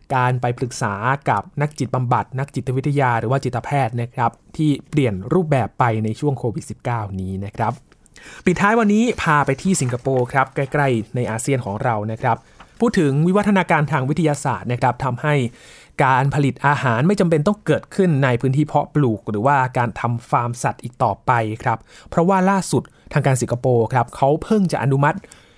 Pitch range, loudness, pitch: 120-150 Hz, -19 LUFS, 135 Hz